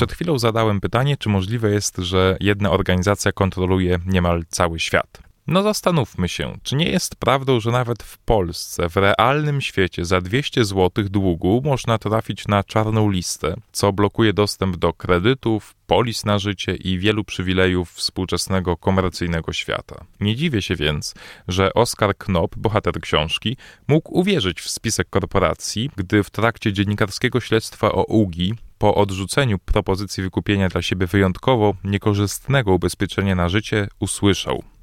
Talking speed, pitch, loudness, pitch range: 145 wpm, 100 Hz, -20 LUFS, 95-110 Hz